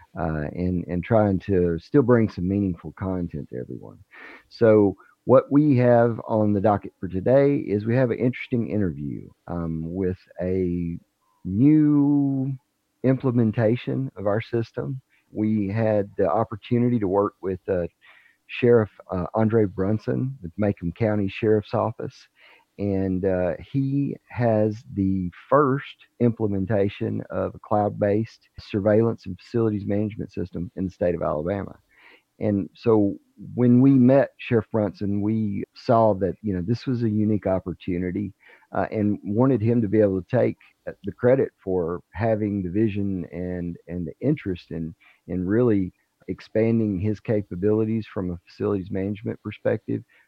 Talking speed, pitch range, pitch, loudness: 140 wpm, 95-115 Hz, 105 Hz, -23 LUFS